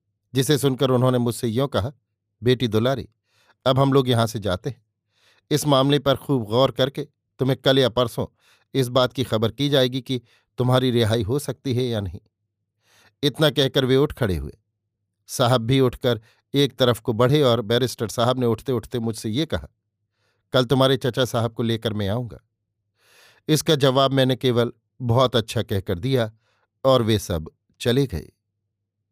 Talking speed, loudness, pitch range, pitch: 170 wpm, -22 LUFS, 110-135 Hz, 120 Hz